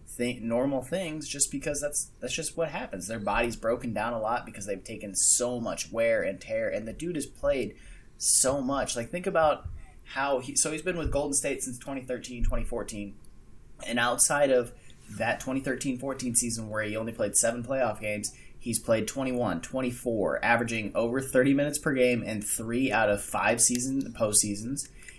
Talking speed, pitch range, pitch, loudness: 180 wpm, 110-135 Hz, 125 Hz, -28 LUFS